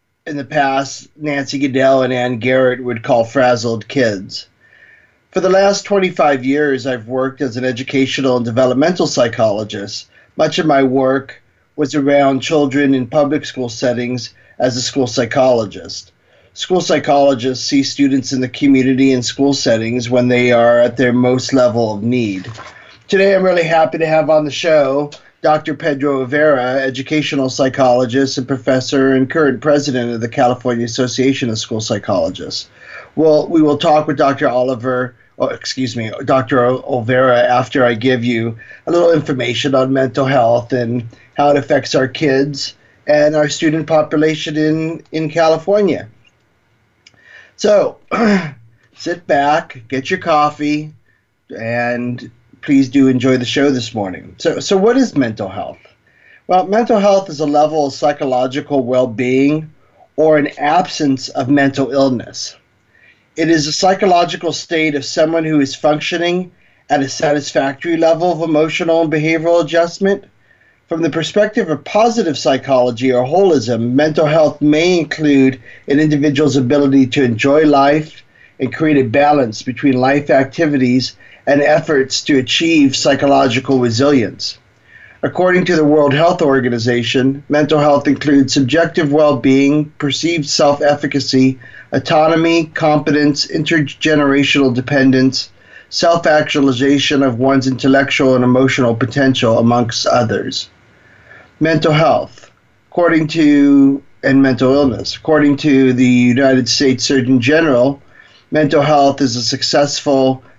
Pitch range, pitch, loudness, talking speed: 125-155 Hz, 140 Hz, -14 LUFS, 135 wpm